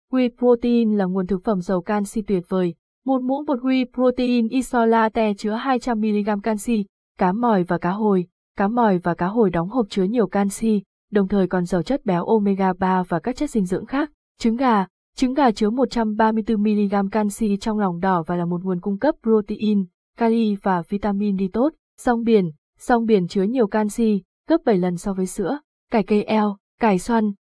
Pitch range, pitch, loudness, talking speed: 195-235 Hz, 215 Hz, -21 LUFS, 195 wpm